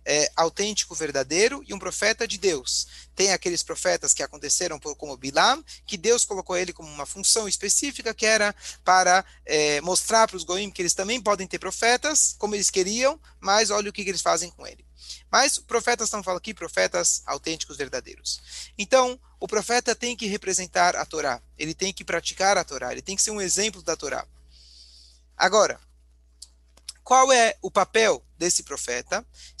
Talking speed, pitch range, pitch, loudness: 175 wpm, 150-210 Hz, 185 Hz, -23 LUFS